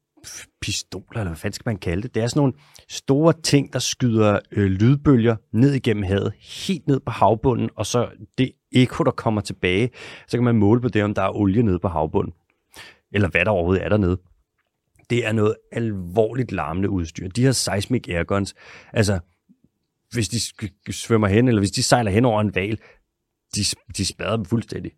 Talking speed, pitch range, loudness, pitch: 190 wpm, 100-120 Hz, -21 LUFS, 110 Hz